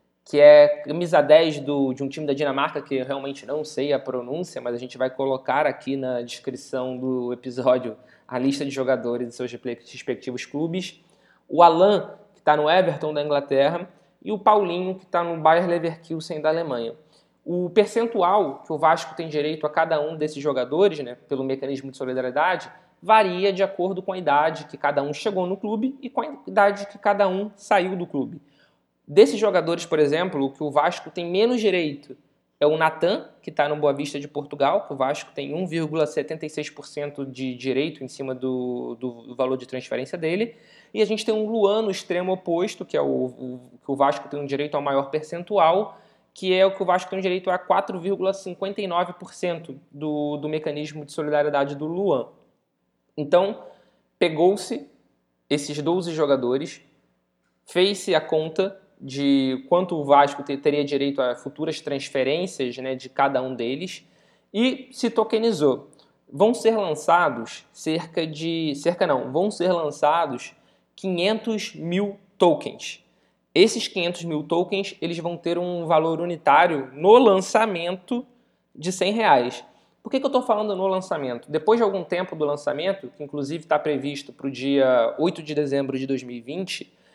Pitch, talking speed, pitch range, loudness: 155 Hz, 170 wpm, 140-185 Hz, -23 LUFS